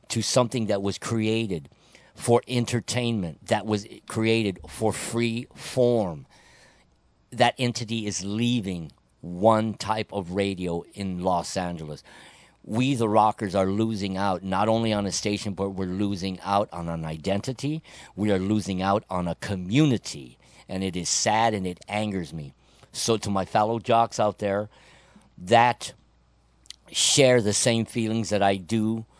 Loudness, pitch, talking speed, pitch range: -25 LUFS, 105 Hz, 150 wpm, 95-115 Hz